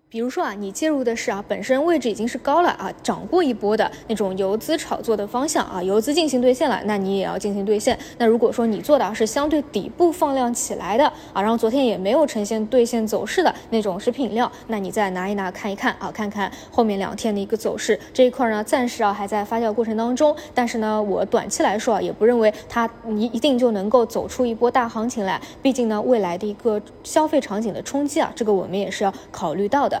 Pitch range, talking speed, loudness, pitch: 205-255 Hz, 355 characters per minute, -21 LUFS, 230 Hz